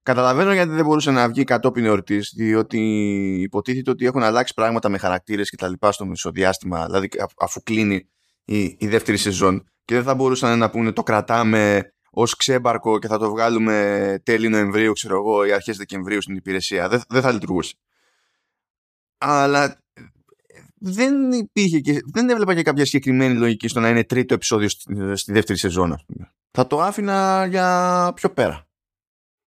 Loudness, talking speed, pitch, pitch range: -20 LUFS, 170 wpm, 110 Hz, 100-130 Hz